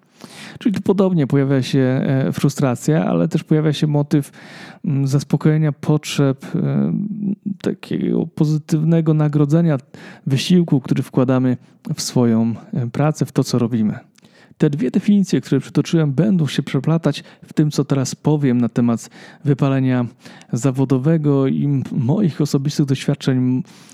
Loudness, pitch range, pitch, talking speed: -18 LUFS, 135-165 Hz, 150 Hz, 115 wpm